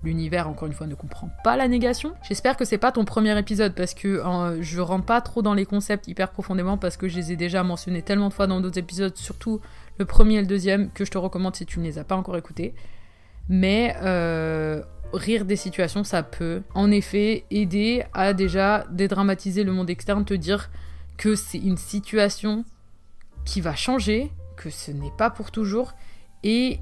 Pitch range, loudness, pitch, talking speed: 175-210 Hz, -24 LUFS, 195 Hz, 205 wpm